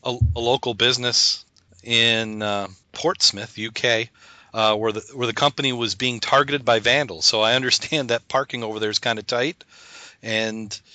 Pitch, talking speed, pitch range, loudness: 115 Hz, 170 wpm, 110-125 Hz, -20 LUFS